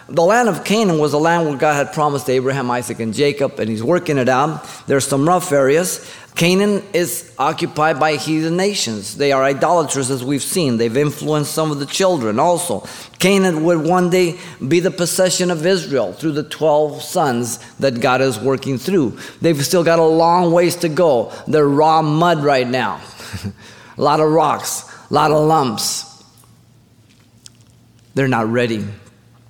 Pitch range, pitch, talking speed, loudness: 130-170 Hz, 150 Hz, 175 wpm, -16 LUFS